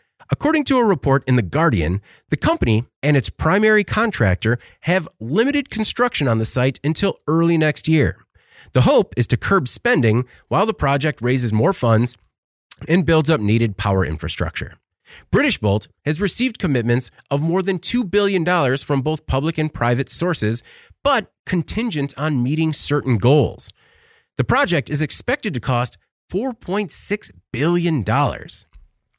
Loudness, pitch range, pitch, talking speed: -19 LUFS, 120-180 Hz, 145 Hz, 145 wpm